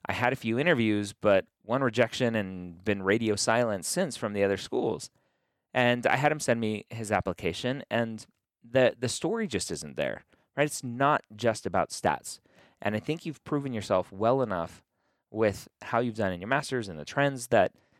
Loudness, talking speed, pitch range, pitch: -29 LUFS, 190 wpm, 105-130 Hz, 115 Hz